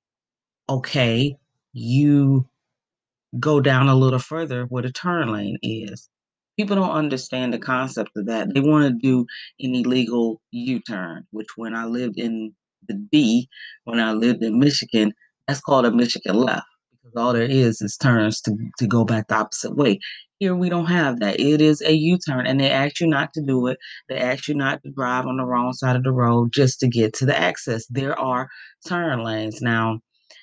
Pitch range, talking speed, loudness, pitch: 115-145 Hz, 195 wpm, -21 LUFS, 130 Hz